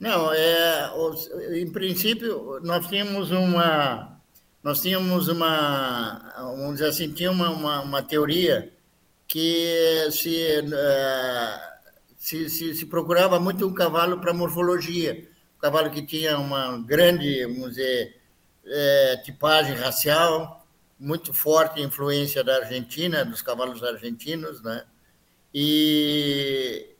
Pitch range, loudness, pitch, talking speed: 140-170 Hz, -23 LUFS, 155 Hz, 110 wpm